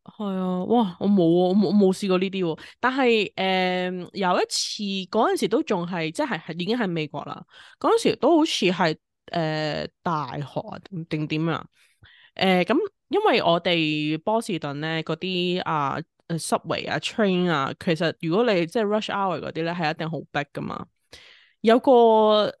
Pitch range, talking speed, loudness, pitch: 160-210 Hz, 275 characters per minute, -23 LUFS, 180 Hz